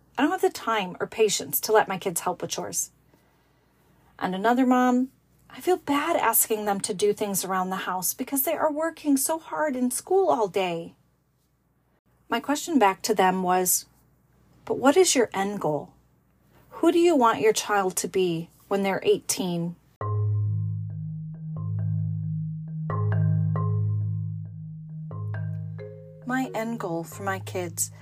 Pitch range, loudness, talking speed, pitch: 145-235 Hz, -25 LUFS, 145 wpm, 190 Hz